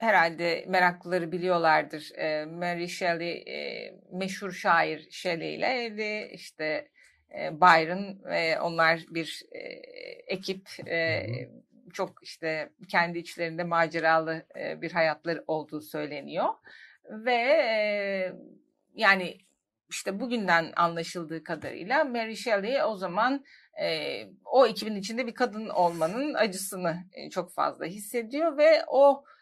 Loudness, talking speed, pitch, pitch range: -28 LUFS, 95 wpm, 185 Hz, 165-245 Hz